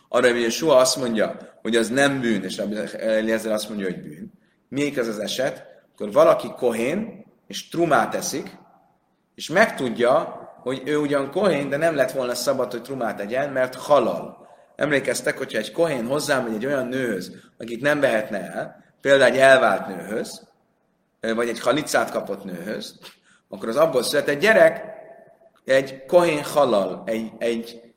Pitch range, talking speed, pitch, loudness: 115-150 Hz, 155 wpm, 130 Hz, -21 LUFS